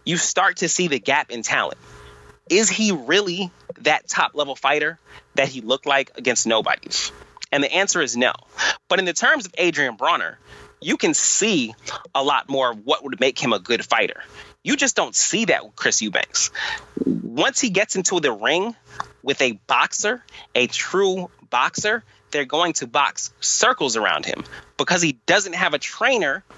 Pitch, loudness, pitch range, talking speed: 180 Hz, -20 LUFS, 130-210 Hz, 180 wpm